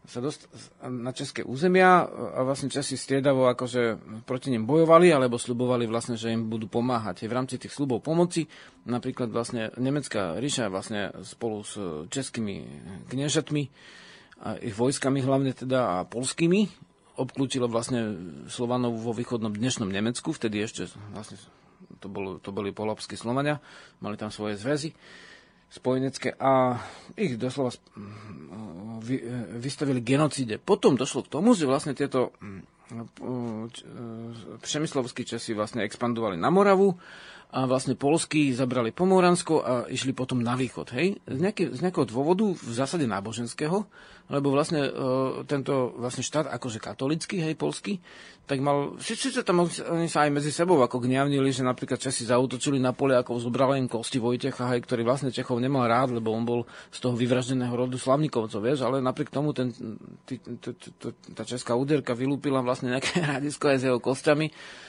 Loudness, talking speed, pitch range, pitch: -27 LUFS, 150 wpm, 120-145 Hz, 130 Hz